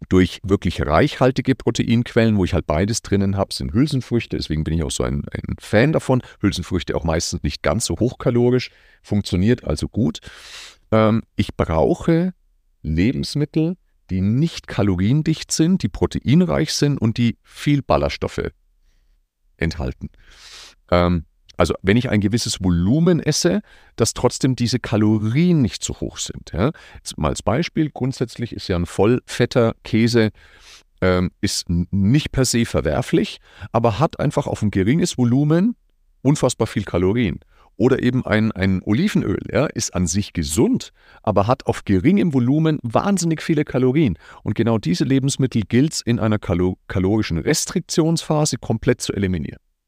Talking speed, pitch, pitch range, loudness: 145 wpm, 115 Hz, 90-135 Hz, -20 LUFS